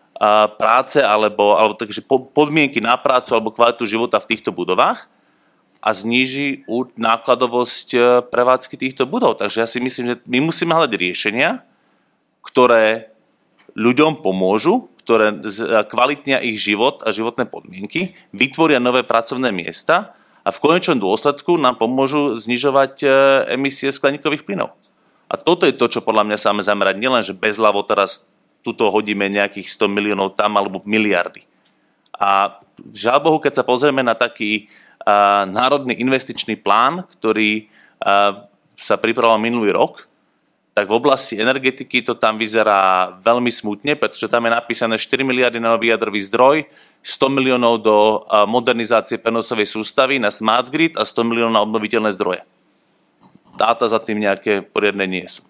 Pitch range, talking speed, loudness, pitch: 105-130 Hz, 145 wpm, -17 LUFS, 115 Hz